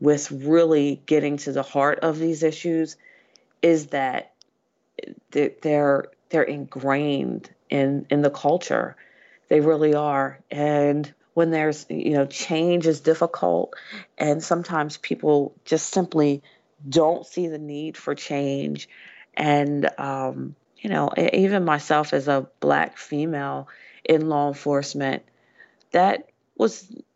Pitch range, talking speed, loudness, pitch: 140-160 Hz, 120 wpm, -23 LUFS, 150 Hz